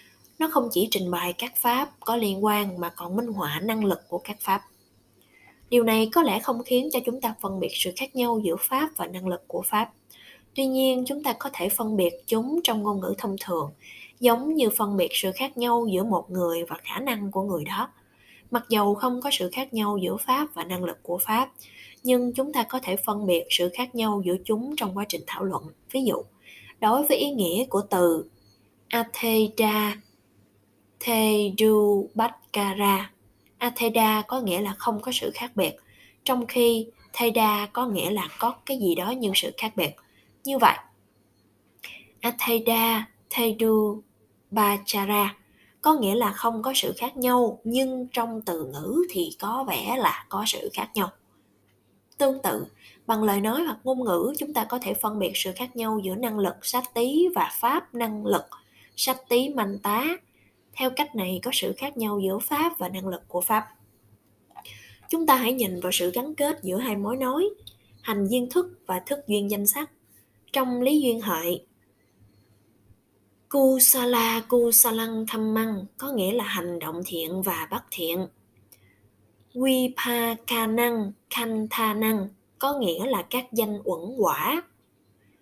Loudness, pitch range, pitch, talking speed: -25 LUFS, 185-250 Hz, 220 Hz, 175 wpm